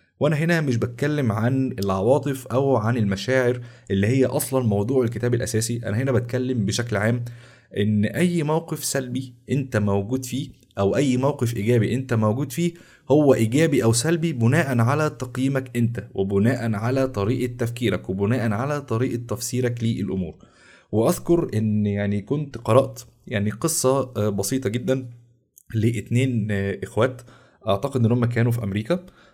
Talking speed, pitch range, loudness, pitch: 135 wpm, 110-130 Hz, -23 LUFS, 120 Hz